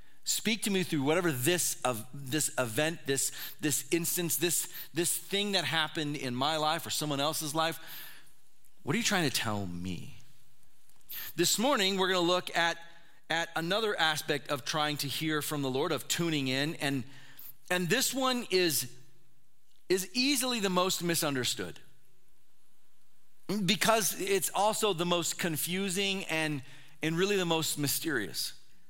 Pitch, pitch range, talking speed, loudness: 160 Hz, 140-185 Hz, 150 wpm, -30 LUFS